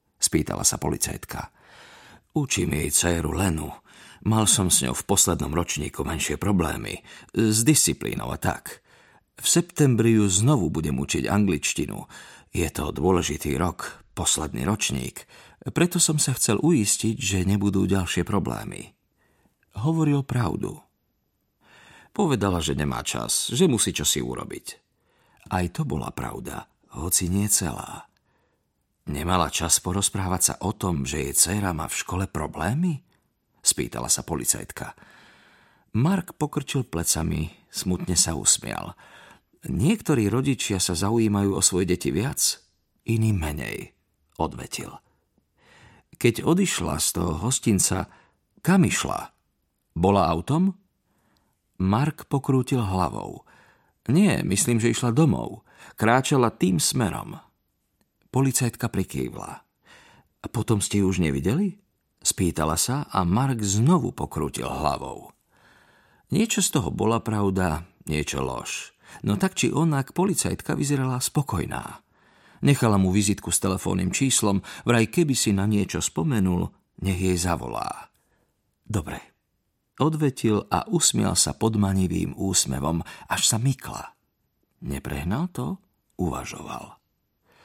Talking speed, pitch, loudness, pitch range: 115 wpm, 100 Hz, -24 LUFS, 85-125 Hz